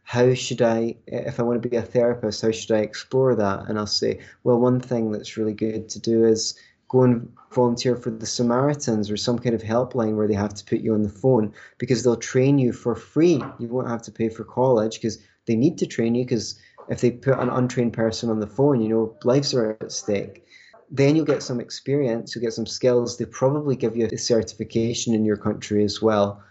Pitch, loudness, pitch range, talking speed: 115 Hz, -23 LUFS, 110-125 Hz, 230 wpm